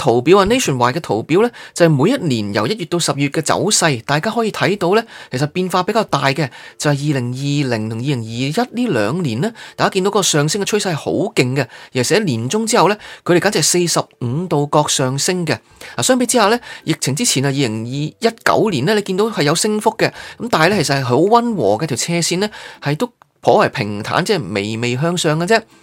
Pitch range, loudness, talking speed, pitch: 140-205 Hz, -16 LUFS, 355 characters per minute, 160 Hz